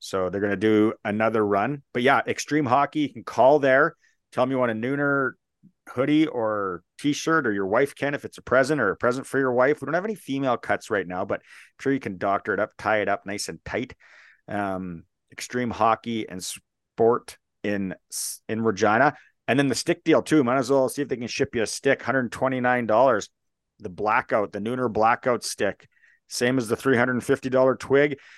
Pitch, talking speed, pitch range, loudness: 125 Hz, 205 wpm, 110-140 Hz, -24 LUFS